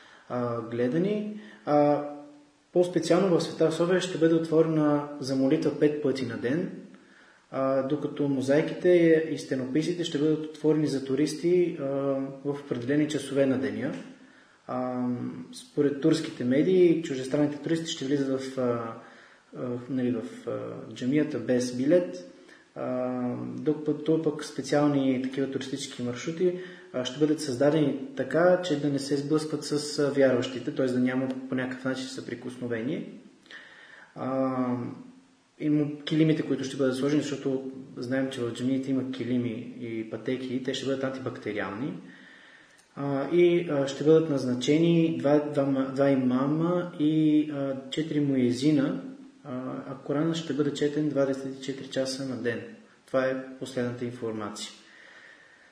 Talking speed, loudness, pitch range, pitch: 125 wpm, -27 LUFS, 130-155 Hz, 140 Hz